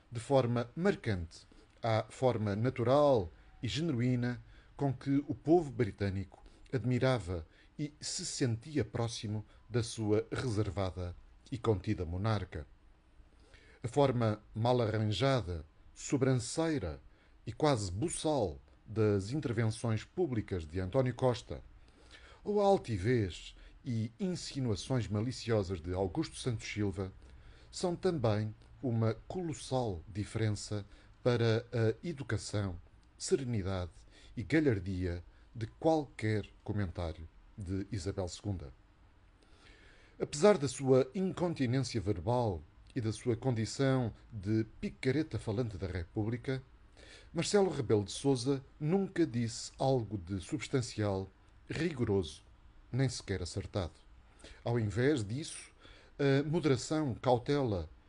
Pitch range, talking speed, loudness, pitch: 100-135 Hz, 100 wpm, -34 LUFS, 110 Hz